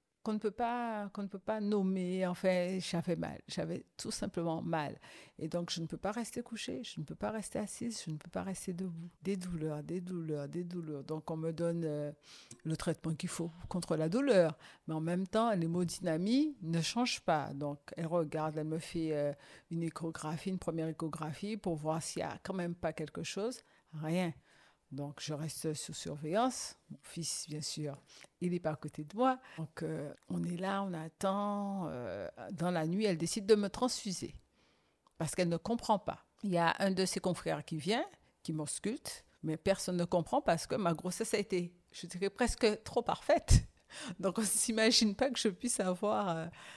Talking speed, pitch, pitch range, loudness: 205 wpm, 175 Hz, 160-205 Hz, -36 LUFS